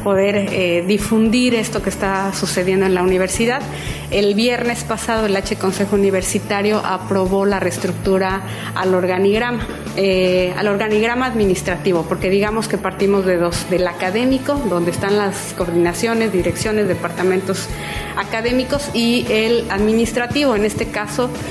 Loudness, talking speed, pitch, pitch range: -17 LUFS, 130 wpm, 200 Hz, 185-220 Hz